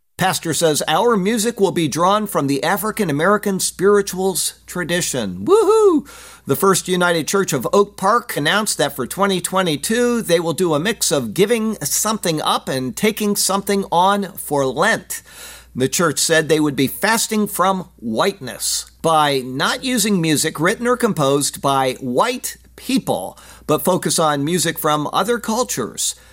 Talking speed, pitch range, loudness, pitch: 150 wpm, 155-210 Hz, -17 LUFS, 185 Hz